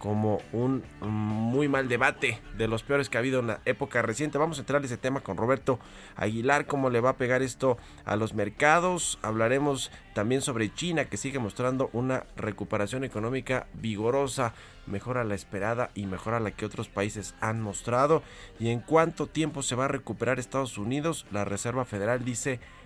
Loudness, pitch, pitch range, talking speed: -29 LUFS, 120 Hz, 105-135 Hz, 190 wpm